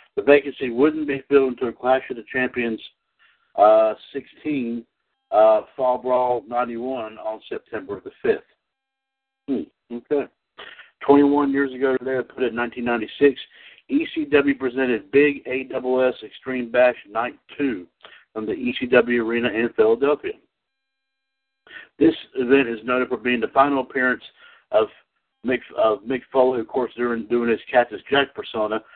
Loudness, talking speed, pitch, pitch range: -21 LUFS, 135 wpm, 130 Hz, 120-145 Hz